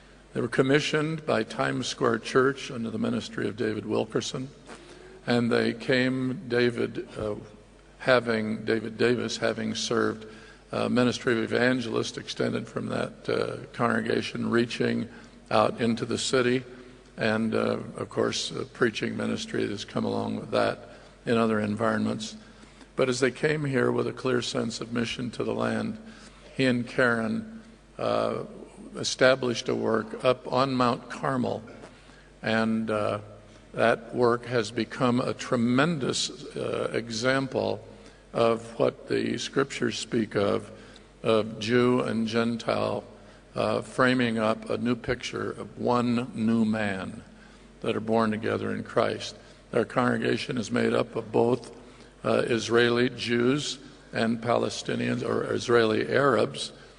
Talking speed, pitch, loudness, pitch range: 135 wpm, 120 Hz, -27 LUFS, 110-125 Hz